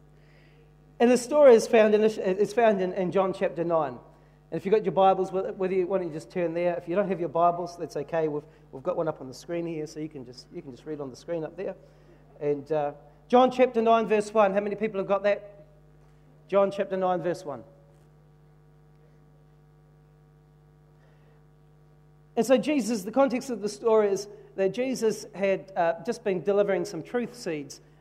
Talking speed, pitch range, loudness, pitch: 200 wpm, 150-205 Hz, -26 LUFS, 170 Hz